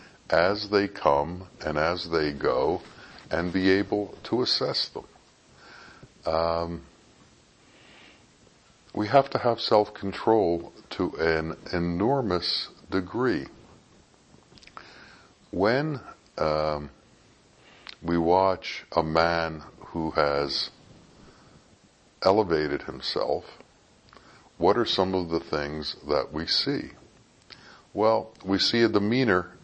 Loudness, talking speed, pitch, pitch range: -26 LUFS, 95 wpm, 85 Hz, 80-100 Hz